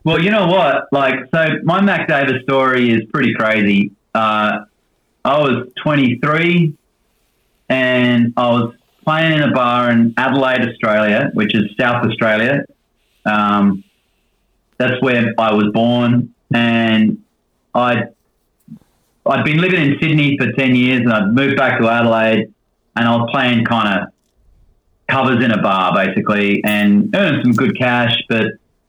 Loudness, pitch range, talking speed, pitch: -14 LUFS, 110-135 Hz, 145 wpm, 120 Hz